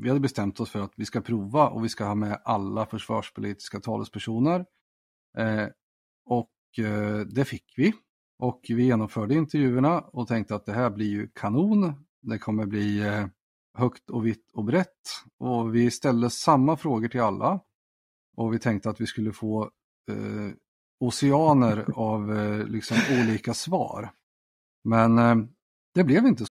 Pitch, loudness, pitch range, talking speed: 115 Hz, -26 LUFS, 105-125 Hz, 160 wpm